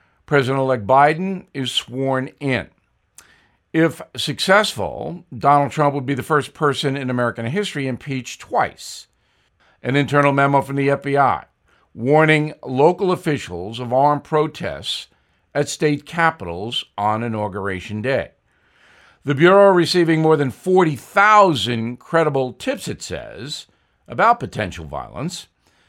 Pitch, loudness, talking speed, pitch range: 140 Hz, -18 LUFS, 120 wpm, 120-155 Hz